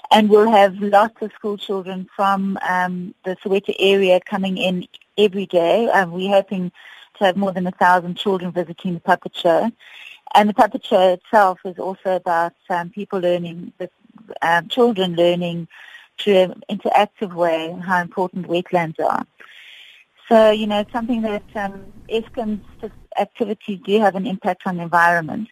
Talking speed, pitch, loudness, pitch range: 160 wpm, 195 Hz, -19 LUFS, 180-210 Hz